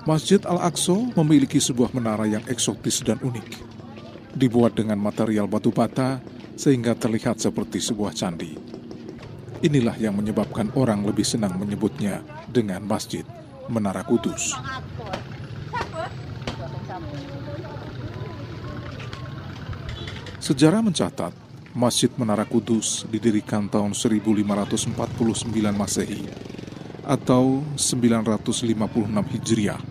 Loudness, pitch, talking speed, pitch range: -23 LUFS, 120 Hz, 85 wpm, 110-130 Hz